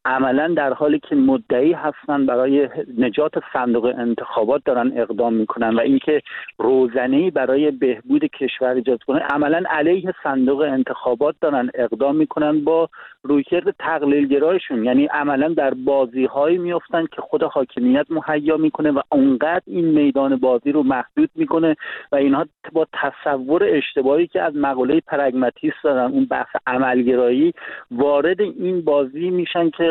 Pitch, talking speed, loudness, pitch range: 150 Hz, 140 wpm, -19 LUFS, 135-175 Hz